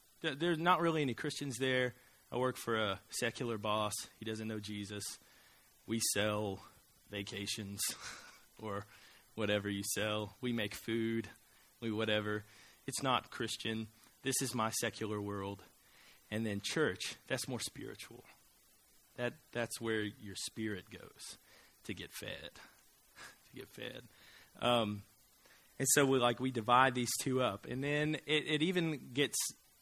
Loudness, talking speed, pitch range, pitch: -37 LUFS, 140 wpm, 105-130 Hz, 115 Hz